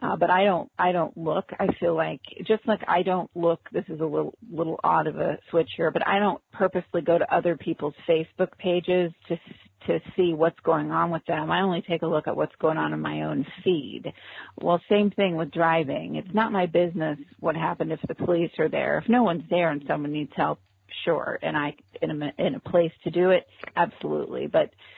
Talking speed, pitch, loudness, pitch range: 225 wpm, 170 Hz, -25 LUFS, 160-180 Hz